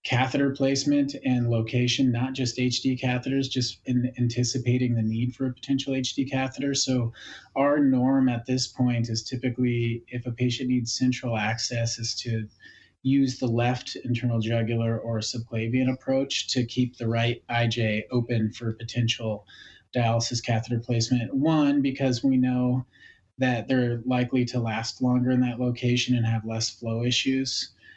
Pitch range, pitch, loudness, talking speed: 115-130 Hz, 125 Hz, -26 LUFS, 150 wpm